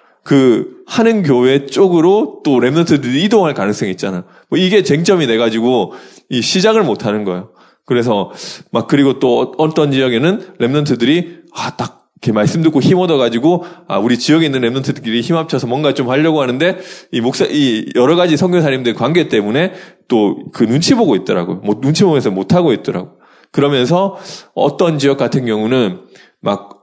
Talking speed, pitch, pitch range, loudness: 360 characters per minute, 145 Hz, 125-175 Hz, -13 LUFS